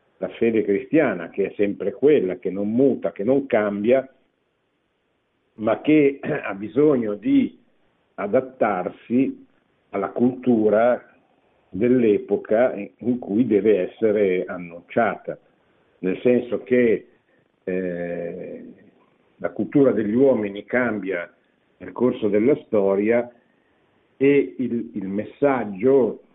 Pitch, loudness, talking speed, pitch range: 120 Hz, -21 LUFS, 100 wpm, 100-135 Hz